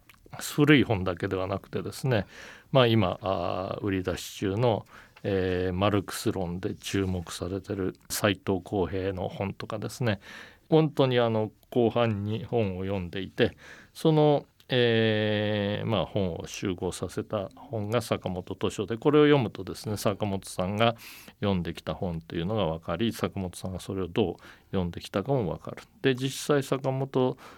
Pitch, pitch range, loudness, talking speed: 105 Hz, 95-115 Hz, -28 LUFS, 295 characters per minute